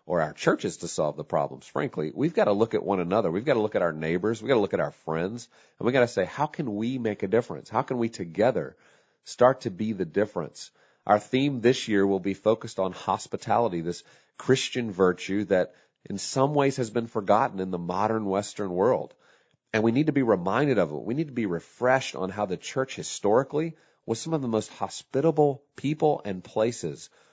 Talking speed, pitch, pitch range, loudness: 220 wpm, 110 Hz, 100-130 Hz, -27 LUFS